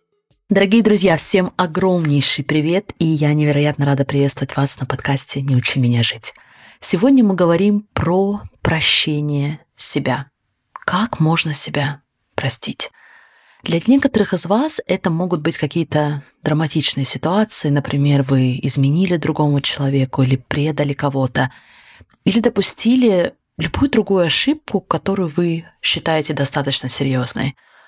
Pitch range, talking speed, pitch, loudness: 140-185 Hz, 120 wpm, 155 Hz, -17 LUFS